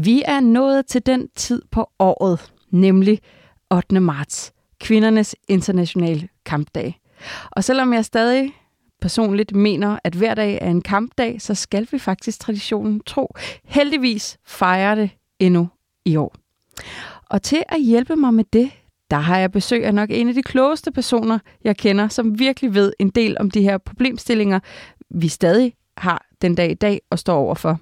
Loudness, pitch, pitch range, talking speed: -18 LUFS, 210 Hz, 185-240 Hz, 165 wpm